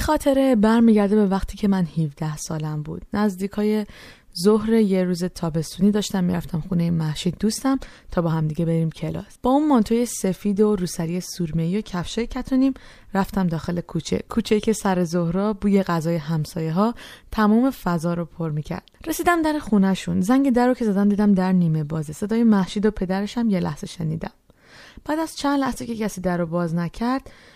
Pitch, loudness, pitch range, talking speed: 195 Hz, -22 LUFS, 170-225 Hz, 180 wpm